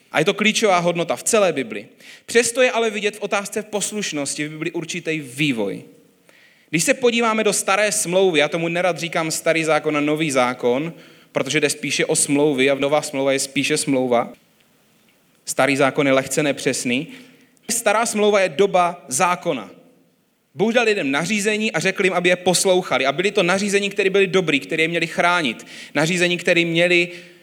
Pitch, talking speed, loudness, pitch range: 175 Hz, 175 wpm, -19 LUFS, 150-205 Hz